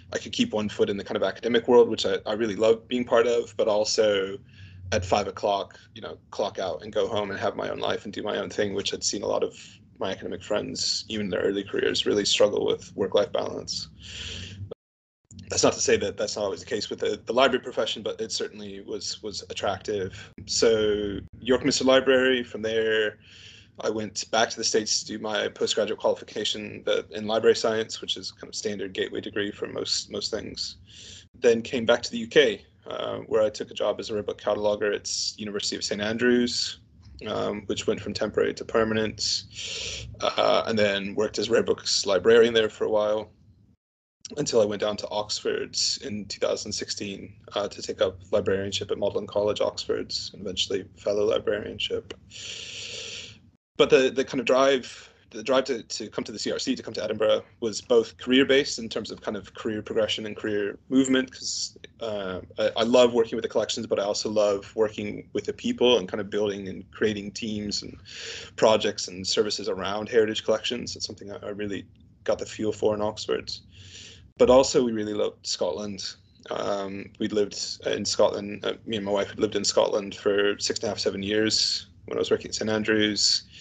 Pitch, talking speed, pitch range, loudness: 110 Hz, 200 wpm, 105-145 Hz, -26 LUFS